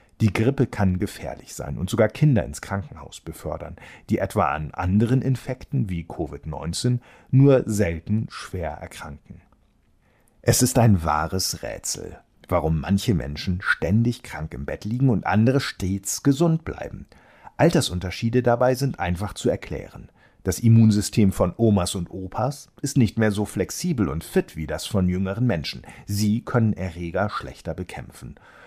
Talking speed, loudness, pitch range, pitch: 145 wpm, -23 LUFS, 90-120 Hz, 105 Hz